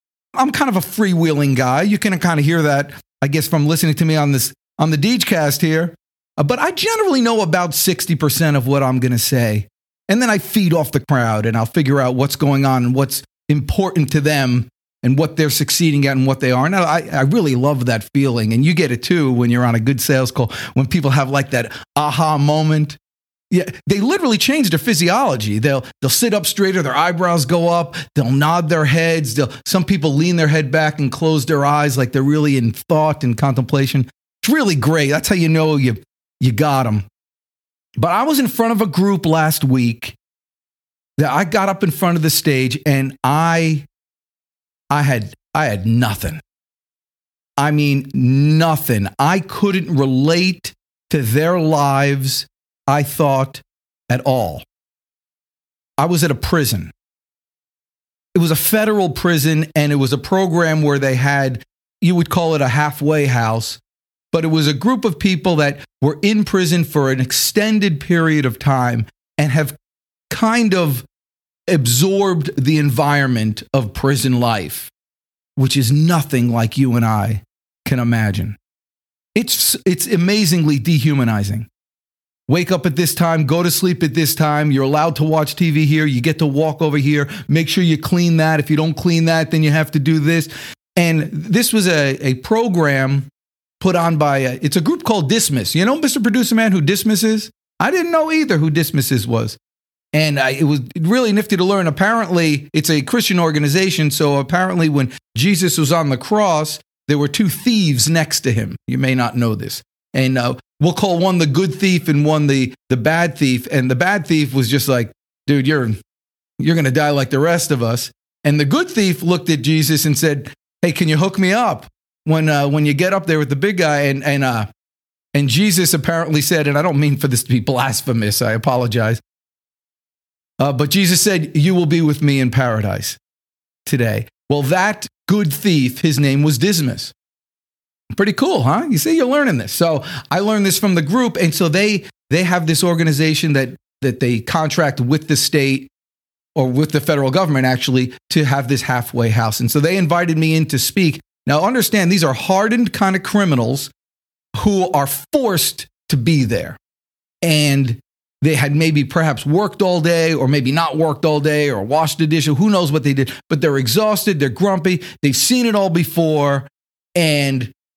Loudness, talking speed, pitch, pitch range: -16 LUFS, 195 wpm, 150 Hz, 135-175 Hz